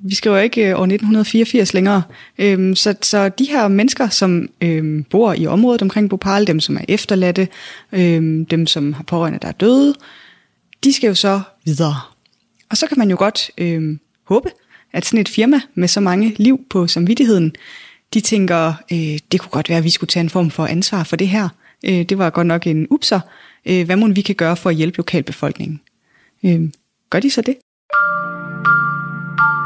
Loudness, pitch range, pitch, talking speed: -16 LUFS, 170-220 Hz, 195 Hz, 190 wpm